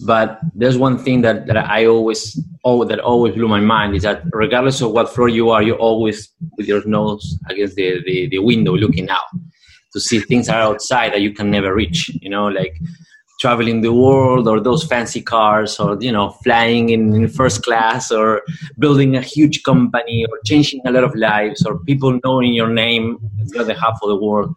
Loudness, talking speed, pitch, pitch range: -15 LUFS, 205 wpm, 115 Hz, 105-125 Hz